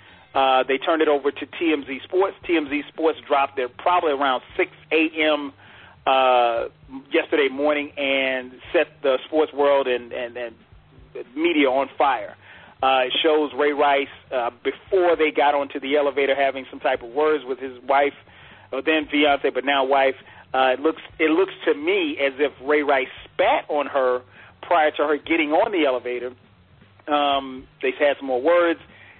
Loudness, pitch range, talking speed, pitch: -21 LUFS, 130-150 Hz, 170 wpm, 140 Hz